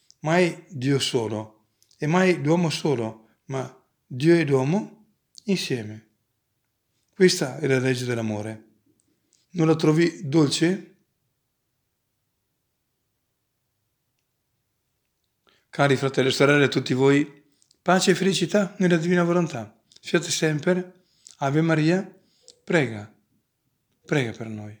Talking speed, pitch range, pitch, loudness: 100 wpm, 120-170 Hz, 140 Hz, -23 LUFS